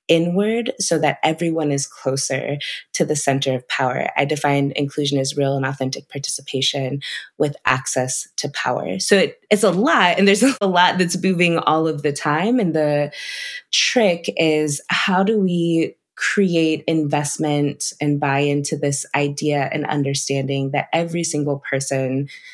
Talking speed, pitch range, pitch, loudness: 155 wpm, 140-170 Hz, 150 Hz, -19 LUFS